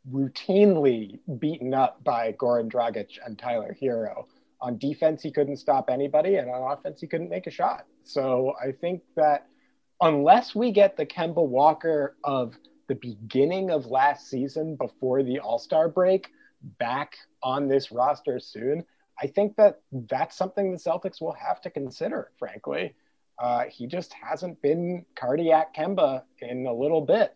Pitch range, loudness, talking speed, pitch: 130-175 Hz, -26 LUFS, 160 wpm, 150 Hz